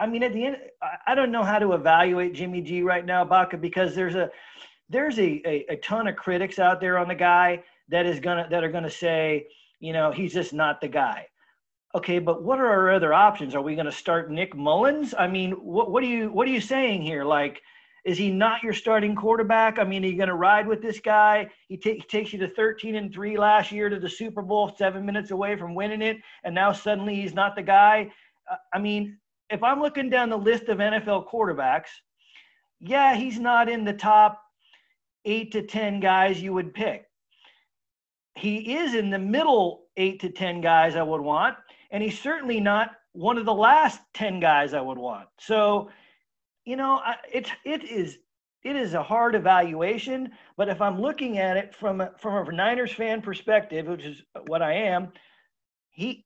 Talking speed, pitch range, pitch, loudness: 205 wpm, 180-225 Hz, 205 Hz, -24 LUFS